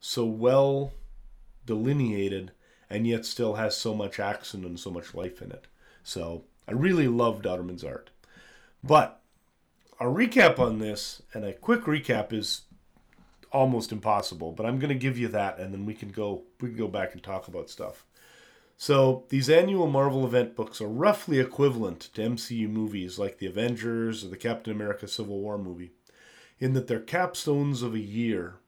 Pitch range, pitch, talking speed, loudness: 100-130 Hz, 115 Hz, 175 wpm, -28 LUFS